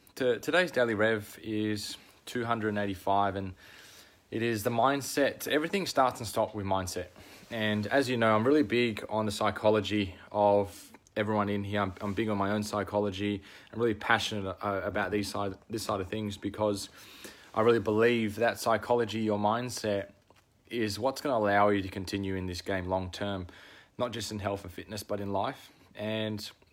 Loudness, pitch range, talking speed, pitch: -30 LUFS, 100-115 Hz, 180 wpm, 105 Hz